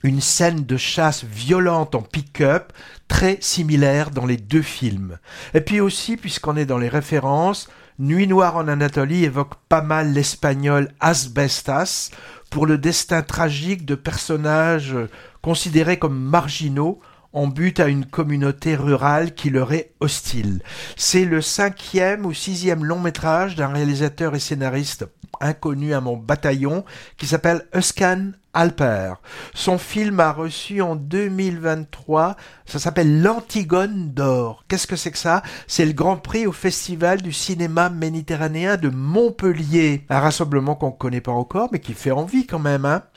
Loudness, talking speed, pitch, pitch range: -20 LUFS, 150 wpm, 160 Hz, 140-175 Hz